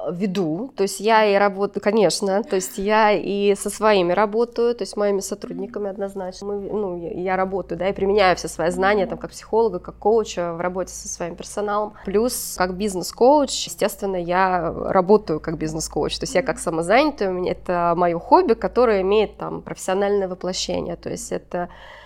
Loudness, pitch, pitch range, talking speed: -21 LUFS, 195 Hz, 180-210 Hz, 175 wpm